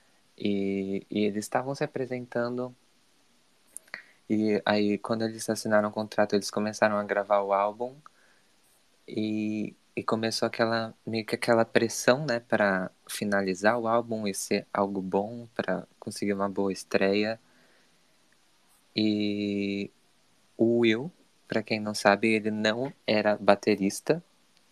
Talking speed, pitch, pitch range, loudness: 125 wpm, 105 Hz, 100-115 Hz, -28 LUFS